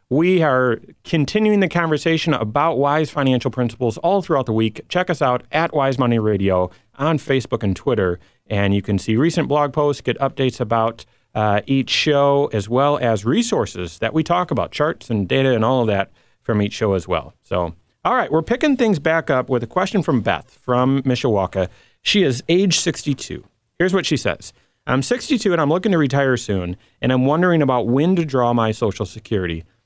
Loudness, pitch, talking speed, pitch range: -19 LUFS, 130 Hz, 195 wpm, 110-160 Hz